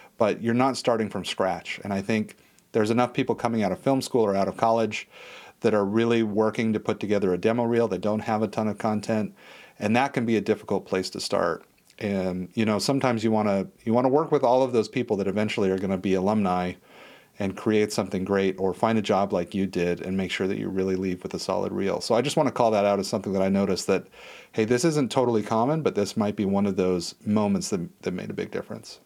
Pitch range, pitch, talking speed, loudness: 95-115 Hz, 110 Hz, 260 wpm, -25 LUFS